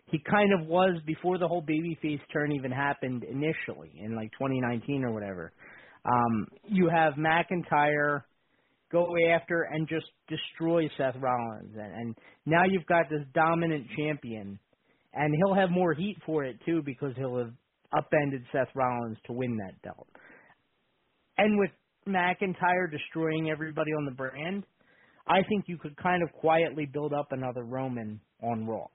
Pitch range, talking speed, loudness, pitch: 130-170 Hz, 155 wpm, -29 LUFS, 155 Hz